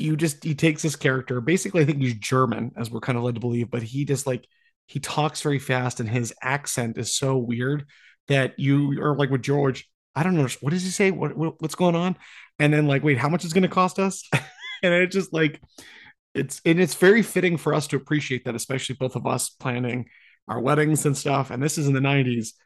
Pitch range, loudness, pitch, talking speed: 130-160 Hz, -23 LUFS, 145 Hz, 235 wpm